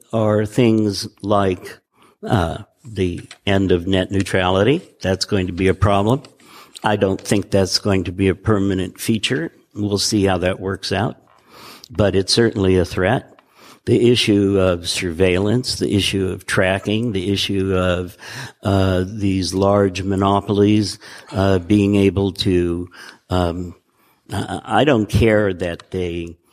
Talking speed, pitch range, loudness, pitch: 140 wpm, 95-105 Hz, -18 LUFS, 100 Hz